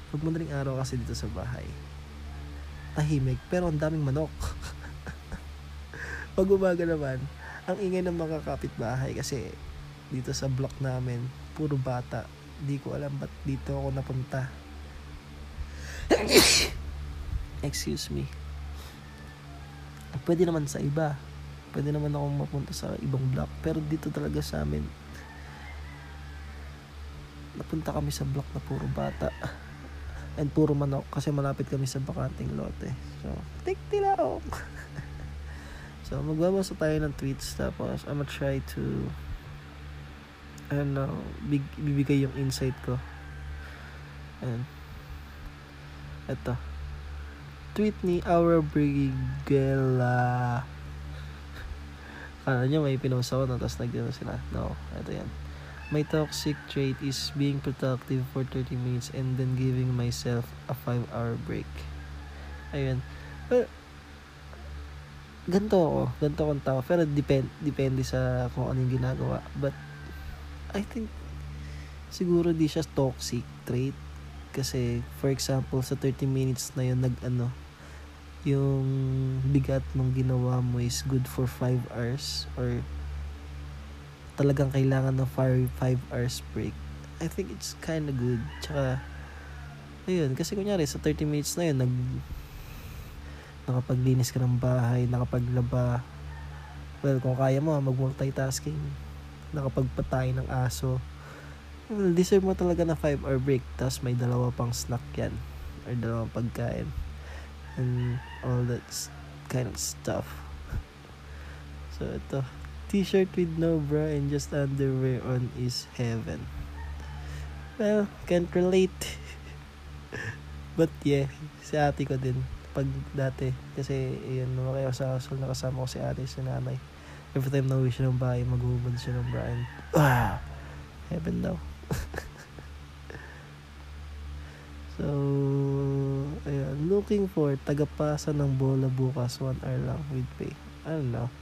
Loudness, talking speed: -30 LUFS, 125 wpm